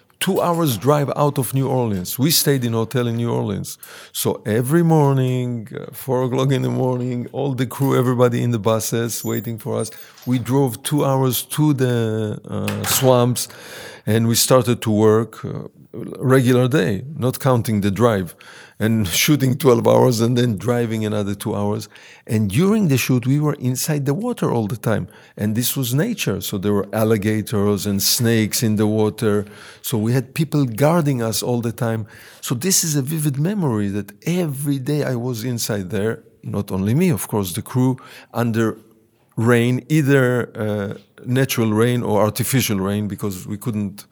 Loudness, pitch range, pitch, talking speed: -19 LUFS, 110-135 Hz, 120 Hz, 175 wpm